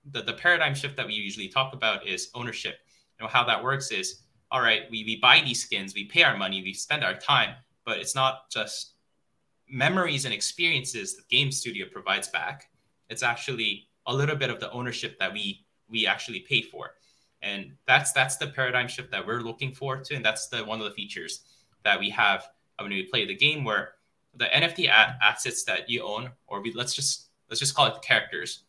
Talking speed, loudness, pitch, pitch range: 210 wpm, -25 LUFS, 125 Hz, 115-140 Hz